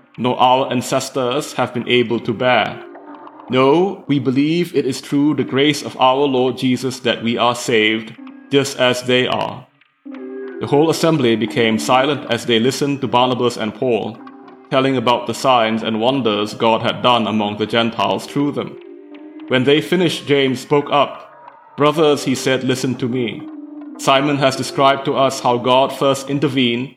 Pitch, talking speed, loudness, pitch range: 130 Hz, 165 wpm, -16 LUFS, 120-145 Hz